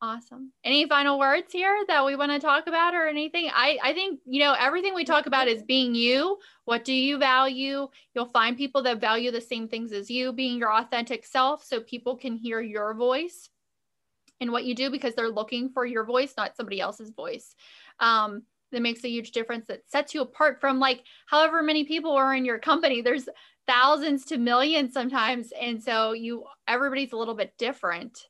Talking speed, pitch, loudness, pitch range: 200 wpm, 260 Hz, -25 LUFS, 235-285 Hz